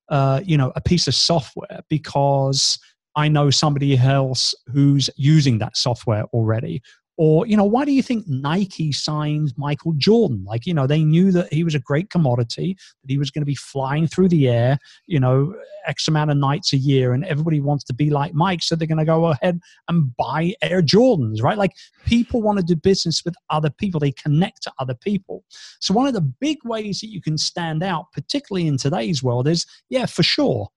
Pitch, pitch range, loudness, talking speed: 155 Hz, 140-180 Hz, -19 LUFS, 210 wpm